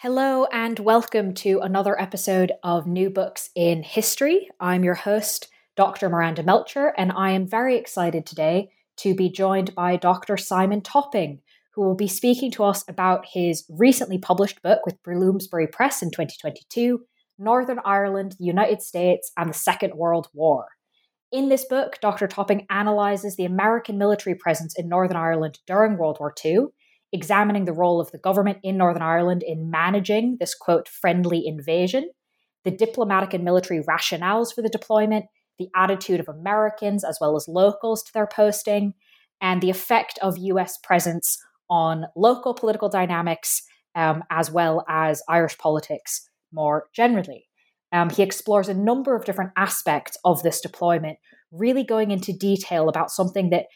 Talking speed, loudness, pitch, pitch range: 160 wpm, -22 LUFS, 190 Hz, 170-210 Hz